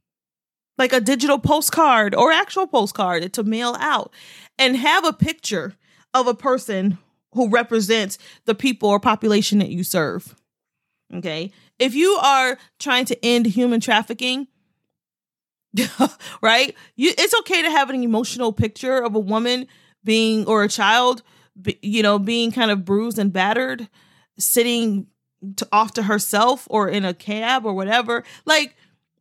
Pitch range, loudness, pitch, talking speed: 205-255 Hz, -19 LUFS, 230 Hz, 145 wpm